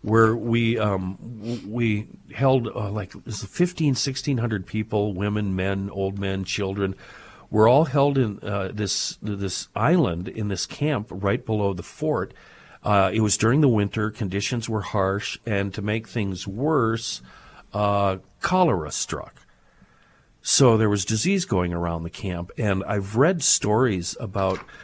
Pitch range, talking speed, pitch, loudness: 100-115 Hz, 150 wpm, 105 Hz, -24 LUFS